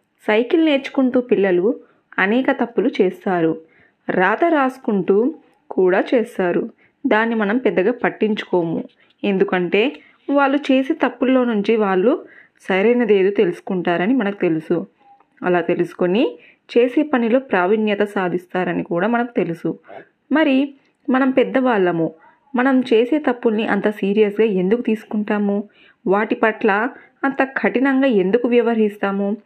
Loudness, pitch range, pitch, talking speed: -18 LUFS, 195-265 Hz, 225 Hz, 100 wpm